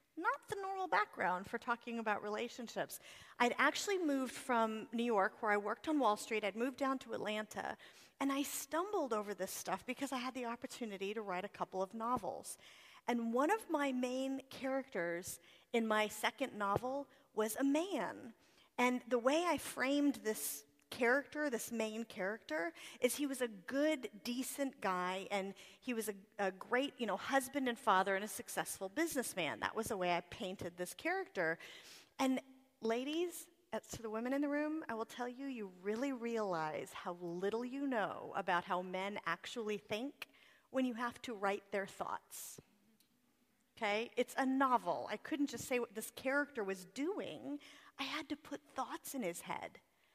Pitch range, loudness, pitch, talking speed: 210-275 Hz, -39 LUFS, 240 Hz, 175 wpm